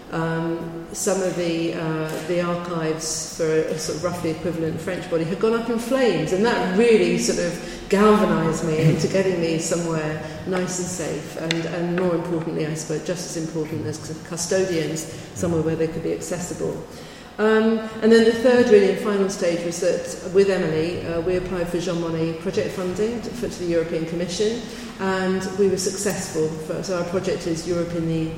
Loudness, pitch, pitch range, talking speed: -22 LUFS, 175 Hz, 165-195 Hz, 190 wpm